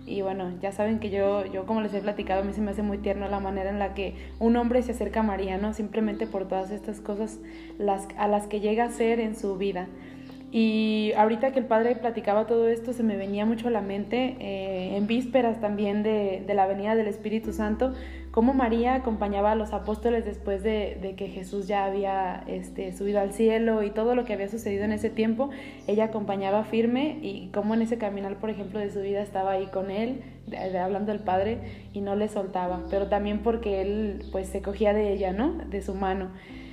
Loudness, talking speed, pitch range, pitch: -27 LUFS, 220 wpm, 195-225 Hz, 205 Hz